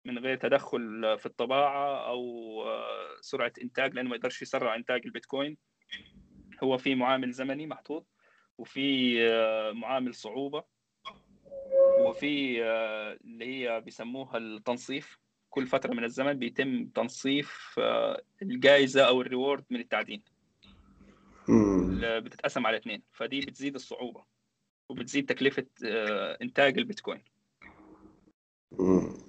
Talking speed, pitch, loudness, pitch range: 100 wpm, 130 Hz, -30 LUFS, 115-140 Hz